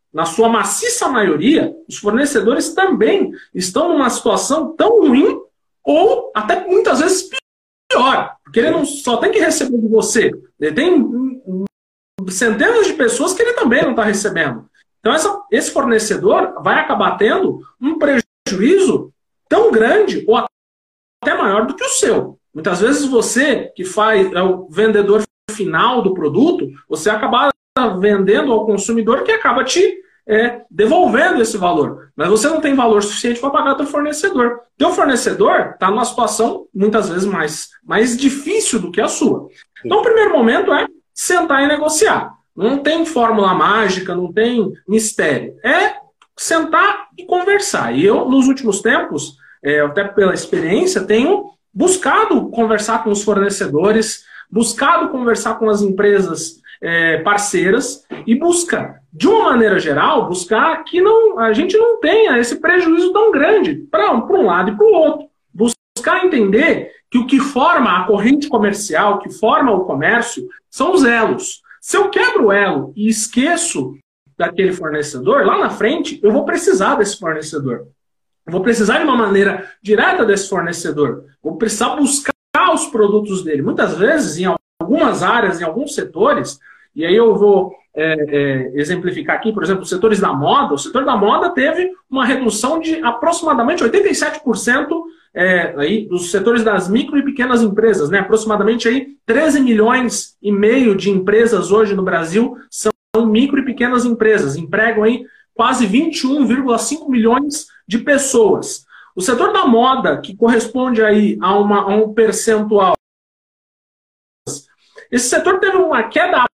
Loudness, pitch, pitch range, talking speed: -14 LUFS, 235 Hz, 205-315 Hz, 155 wpm